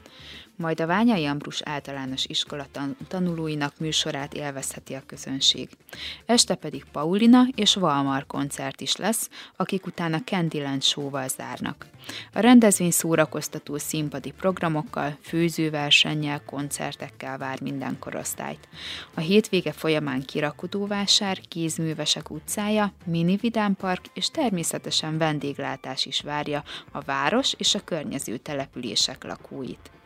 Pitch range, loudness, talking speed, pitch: 145-190 Hz, -25 LUFS, 110 wpm, 160 Hz